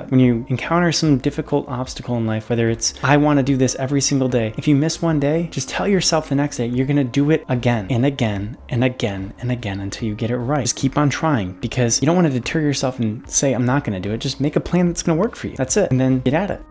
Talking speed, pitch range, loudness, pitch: 295 wpm, 120-145 Hz, -19 LUFS, 130 Hz